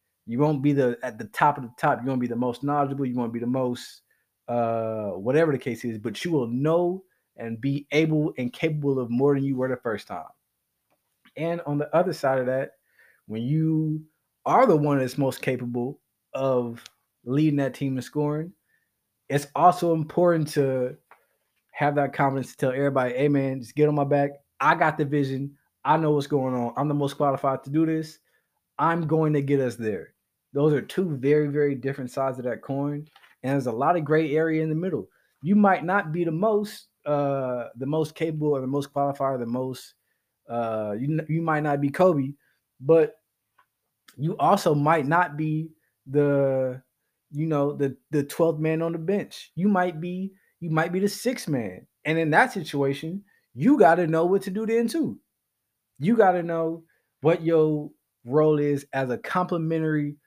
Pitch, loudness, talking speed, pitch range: 145 Hz, -25 LUFS, 195 wpm, 135-160 Hz